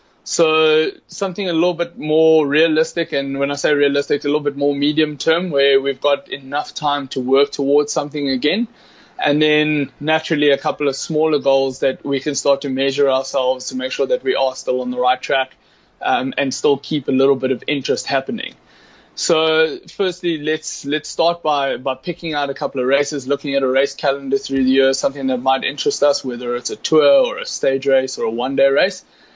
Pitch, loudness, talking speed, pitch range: 145 Hz, -18 LUFS, 210 wpm, 135-155 Hz